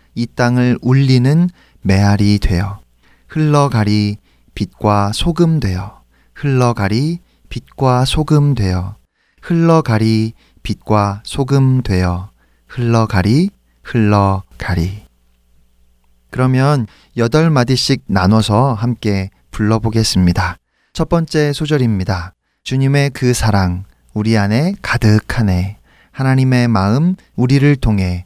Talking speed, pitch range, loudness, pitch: 215 characters per minute, 95-135 Hz, -15 LUFS, 110 Hz